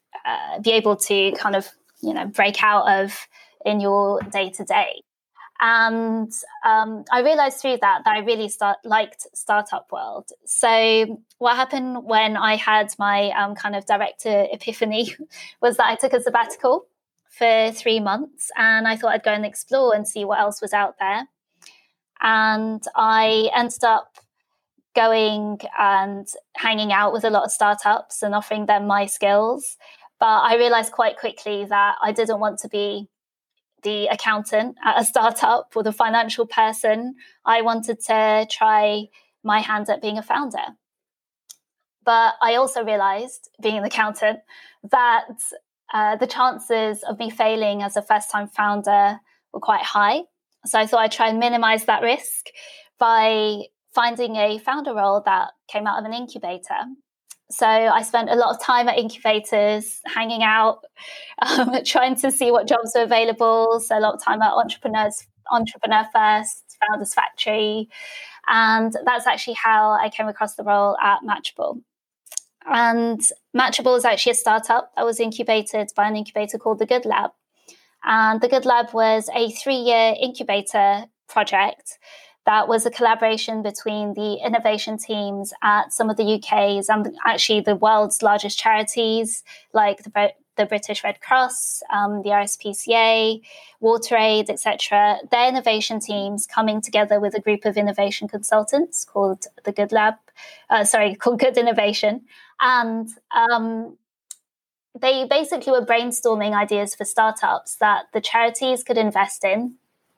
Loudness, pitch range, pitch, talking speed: -20 LUFS, 210-235 Hz, 220 Hz, 155 wpm